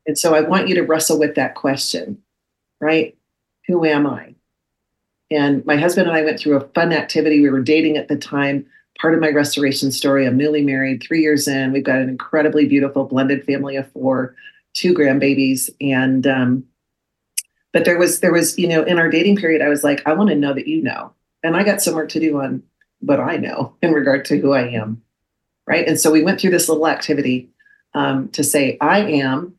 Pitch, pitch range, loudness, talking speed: 150 Hz, 140-165 Hz, -17 LUFS, 215 wpm